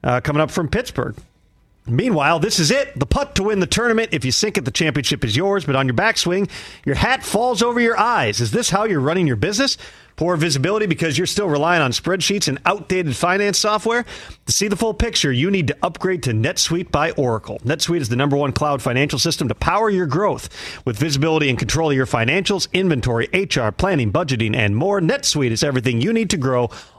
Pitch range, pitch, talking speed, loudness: 130-200 Hz, 160 Hz, 215 wpm, -18 LUFS